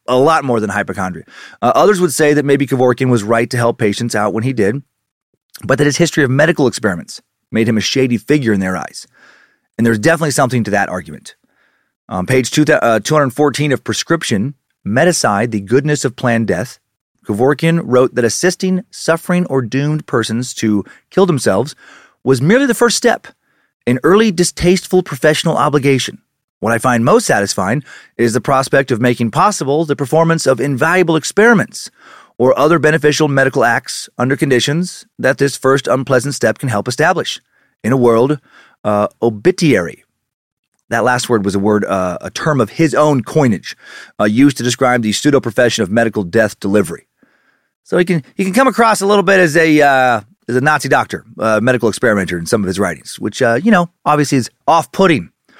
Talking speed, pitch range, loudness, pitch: 180 wpm, 115-160 Hz, -14 LUFS, 135 Hz